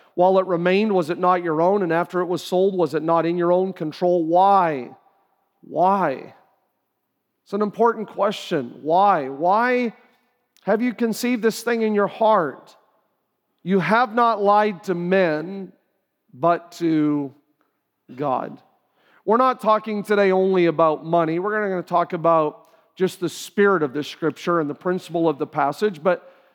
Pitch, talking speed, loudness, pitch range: 180 Hz, 160 wpm, -21 LUFS, 165-210 Hz